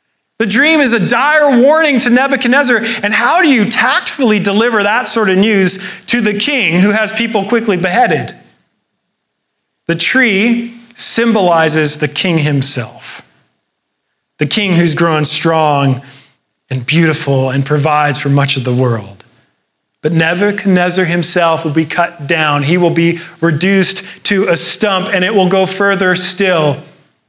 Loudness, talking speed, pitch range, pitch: -11 LUFS, 145 wpm, 155-220 Hz, 185 Hz